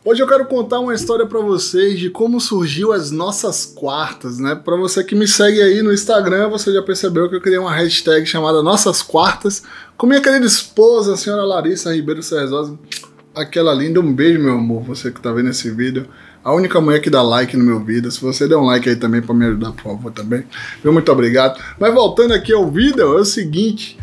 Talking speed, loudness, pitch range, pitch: 215 wpm, -14 LUFS, 130-205 Hz, 175 Hz